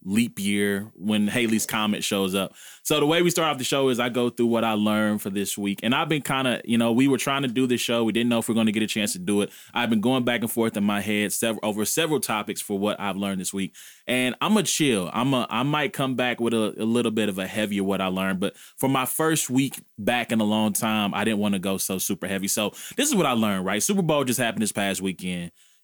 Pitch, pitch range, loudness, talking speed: 110 Hz, 100-125 Hz, -24 LUFS, 290 wpm